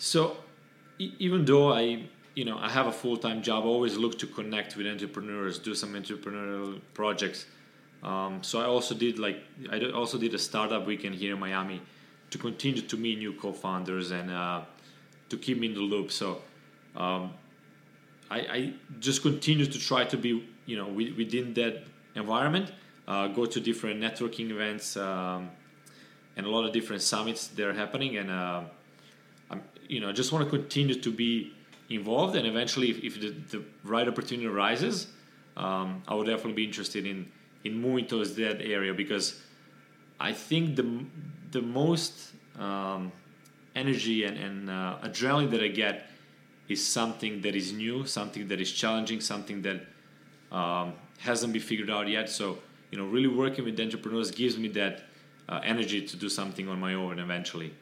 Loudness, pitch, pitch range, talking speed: -31 LUFS, 110 Hz, 100-120 Hz, 170 wpm